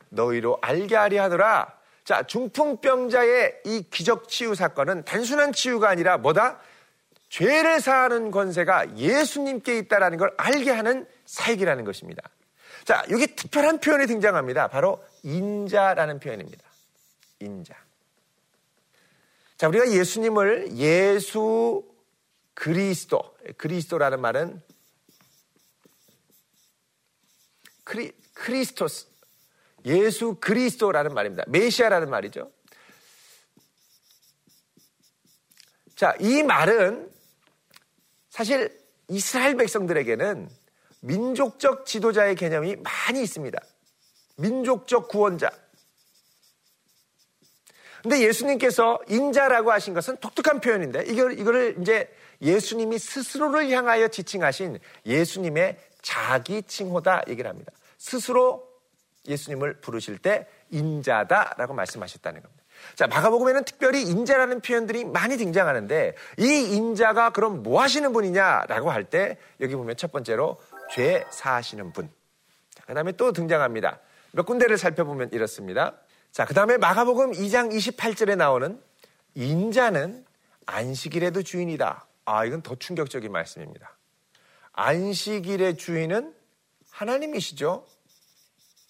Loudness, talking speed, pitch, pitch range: -23 LUFS, 265 characters per minute, 220 Hz, 180-255 Hz